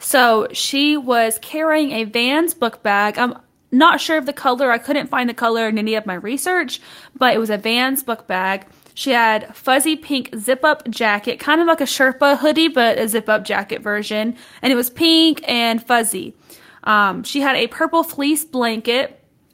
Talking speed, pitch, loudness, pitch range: 185 wpm, 250 Hz, -17 LUFS, 225-290 Hz